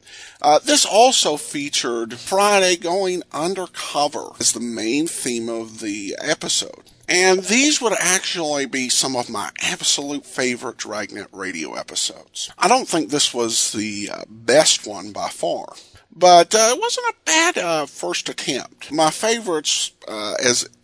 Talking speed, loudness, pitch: 145 wpm, -18 LUFS, 175 Hz